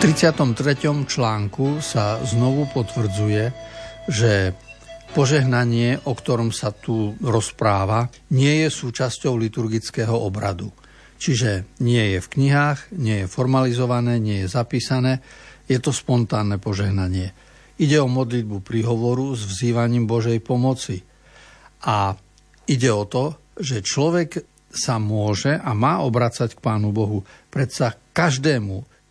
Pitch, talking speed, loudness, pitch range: 120 Hz, 115 wpm, -21 LUFS, 110-135 Hz